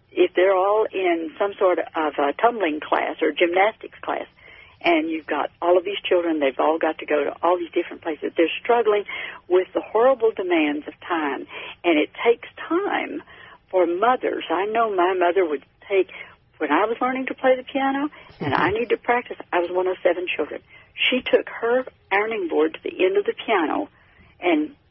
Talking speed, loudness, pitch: 195 wpm, -22 LUFS, 225 Hz